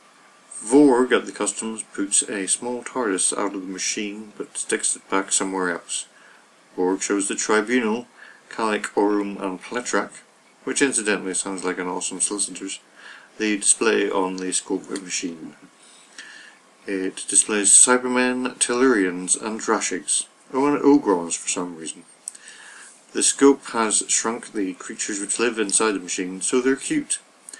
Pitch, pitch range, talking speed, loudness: 105 Hz, 95-125 Hz, 145 wpm, -21 LUFS